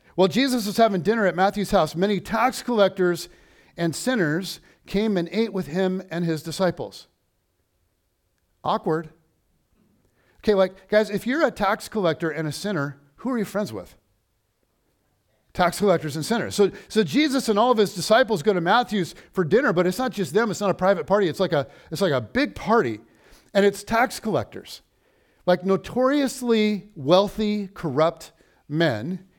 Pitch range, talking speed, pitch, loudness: 160-210 Hz, 165 wpm, 190 Hz, -23 LUFS